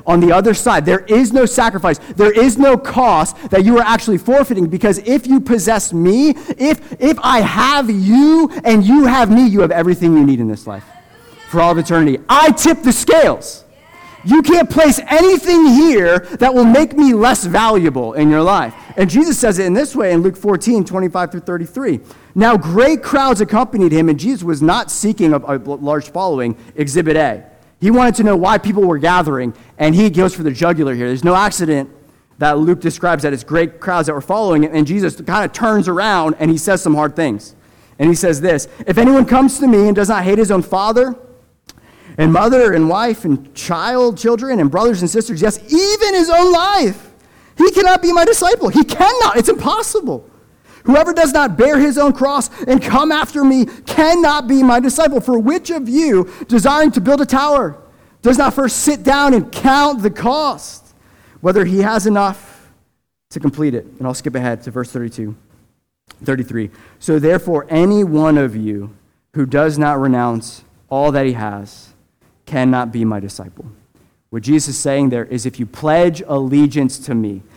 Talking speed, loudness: 195 wpm, -13 LUFS